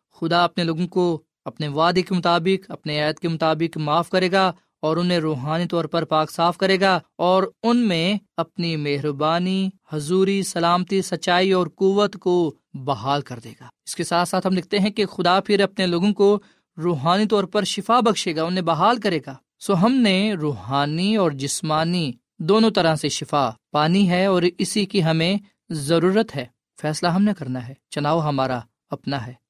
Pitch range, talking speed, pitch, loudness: 155-190 Hz, 180 wpm, 175 Hz, -21 LUFS